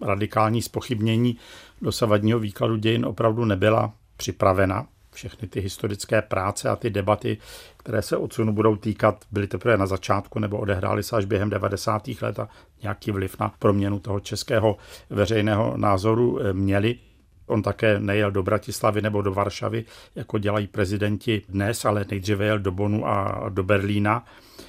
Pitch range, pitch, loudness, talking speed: 100-110 Hz, 105 Hz, -24 LUFS, 150 wpm